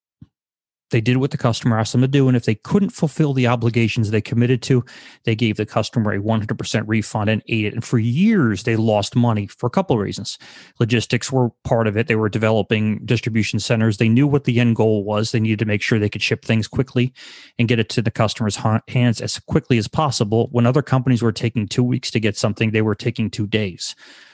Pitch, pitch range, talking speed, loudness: 115 Hz, 110-125 Hz, 230 wpm, -19 LUFS